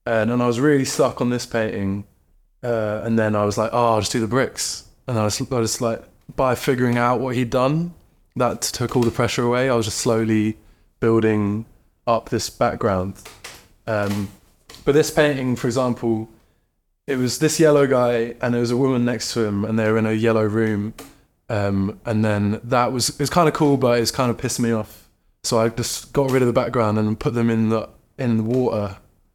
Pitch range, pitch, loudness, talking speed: 110-125 Hz, 115 Hz, -20 LUFS, 215 wpm